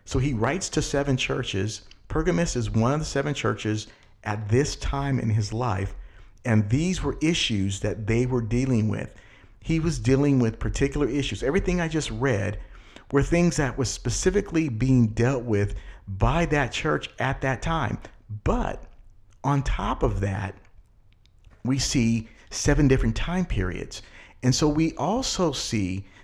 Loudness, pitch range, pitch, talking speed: -25 LUFS, 105-140 Hz, 120 Hz, 155 wpm